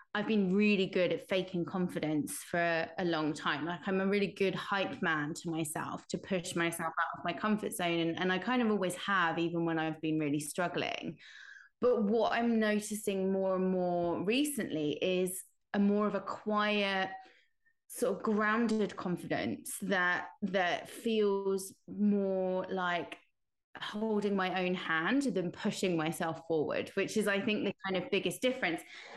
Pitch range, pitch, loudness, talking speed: 170-210 Hz, 190 Hz, -33 LUFS, 165 wpm